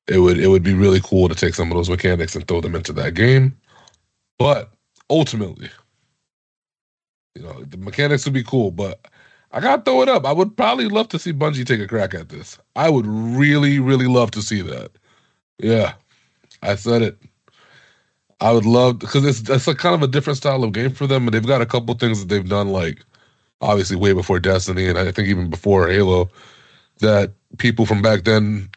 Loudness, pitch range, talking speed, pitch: -18 LUFS, 95-130 Hz, 205 wpm, 110 Hz